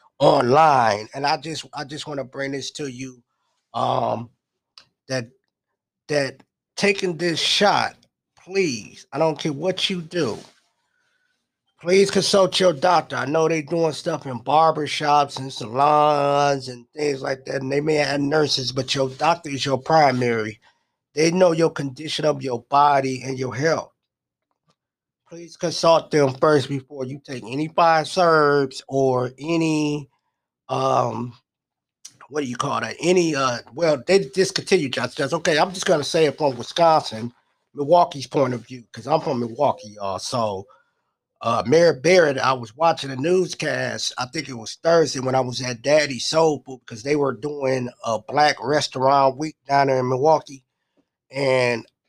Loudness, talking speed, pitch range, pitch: -21 LUFS, 160 wpm, 130-160 Hz, 145 Hz